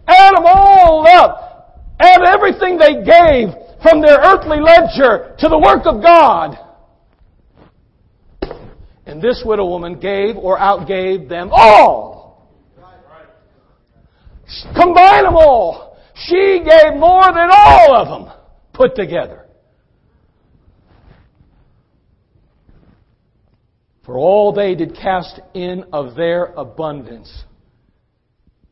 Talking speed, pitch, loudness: 100 wpm, 270 Hz, -9 LUFS